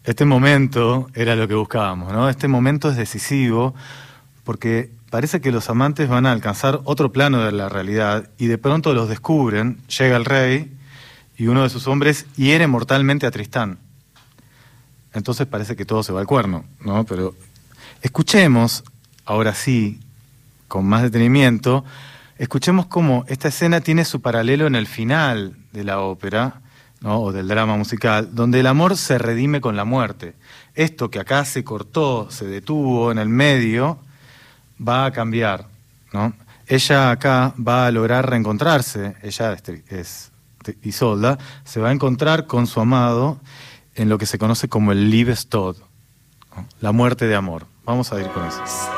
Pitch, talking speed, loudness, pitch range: 125 Hz, 160 wpm, -18 LUFS, 110-135 Hz